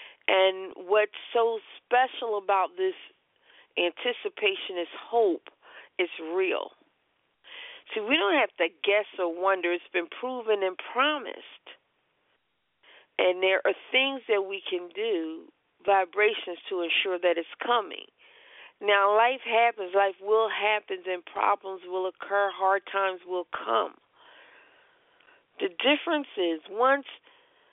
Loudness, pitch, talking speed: -27 LUFS, 225 Hz, 120 wpm